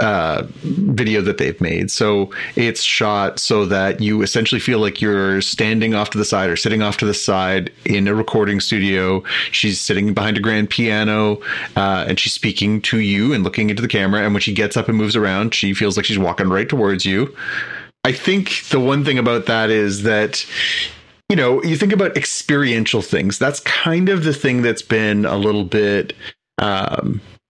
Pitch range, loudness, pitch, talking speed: 100-115 Hz, -17 LUFS, 105 Hz, 195 wpm